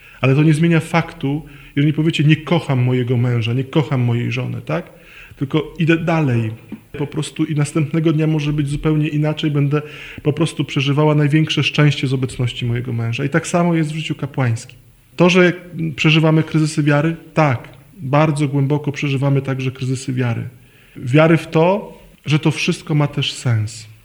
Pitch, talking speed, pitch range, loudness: 150 Hz, 165 wpm, 130-155 Hz, -17 LUFS